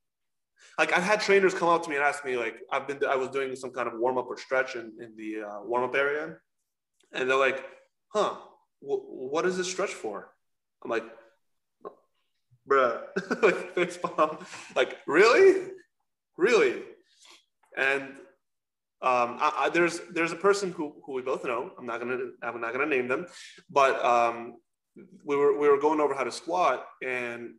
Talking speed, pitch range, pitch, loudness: 175 wpm, 130-195 Hz, 145 Hz, -27 LUFS